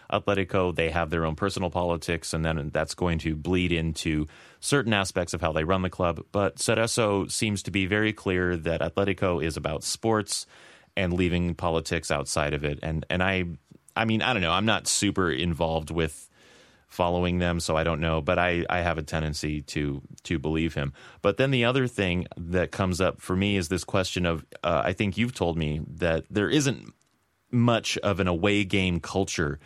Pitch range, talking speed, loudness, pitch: 80-100 Hz, 200 wpm, -26 LUFS, 90 Hz